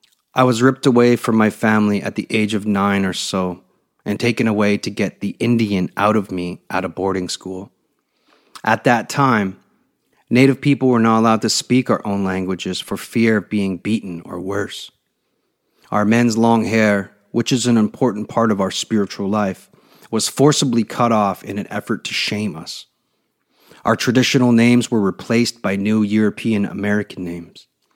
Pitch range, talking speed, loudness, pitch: 100-115 Hz, 175 wpm, -18 LUFS, 110 Hz